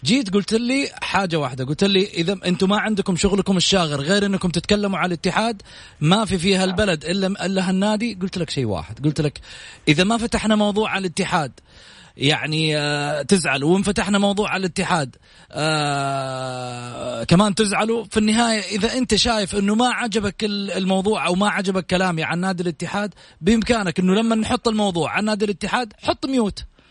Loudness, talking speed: -20 LUFS, 160 wpm